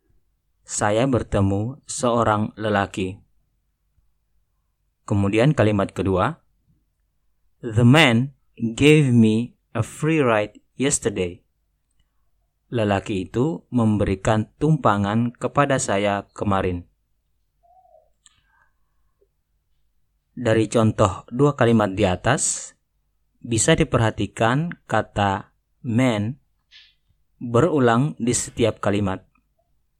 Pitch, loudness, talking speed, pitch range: 110 Hz, -21 LUFS, 70 wpm, 95-125 Hz